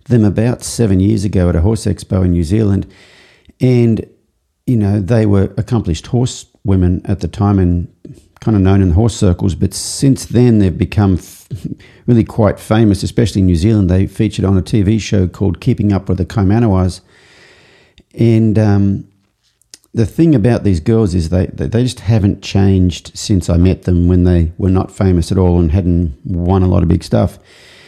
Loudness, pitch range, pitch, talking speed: -13 LUFS, 90-110 Hz, 100 Hz, 185 wpm